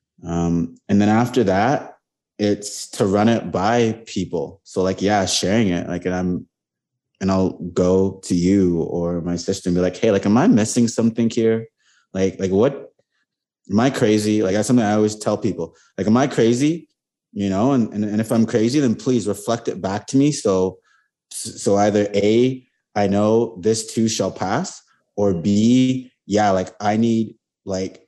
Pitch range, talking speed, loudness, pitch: 95-115 Hz, 185 wpm, -19 LUFS, 105 Hz